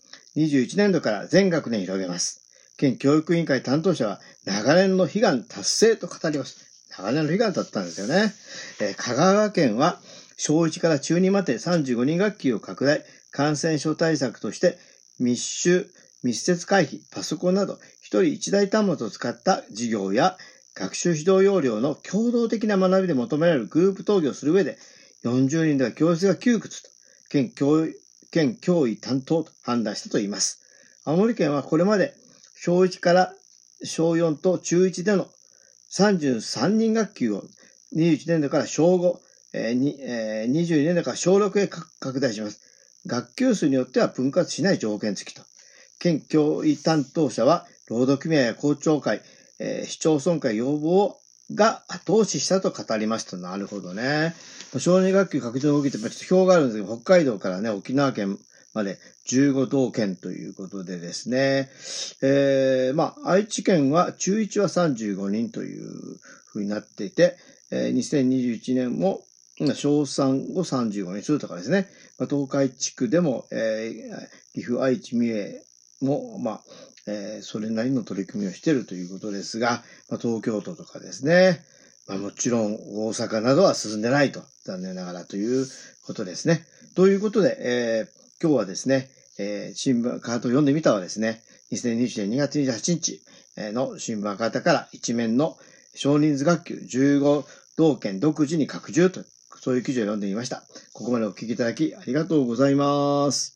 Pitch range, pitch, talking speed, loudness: 120-180 Hz, 145 Hz, 285 characters per minute, -23 LUFS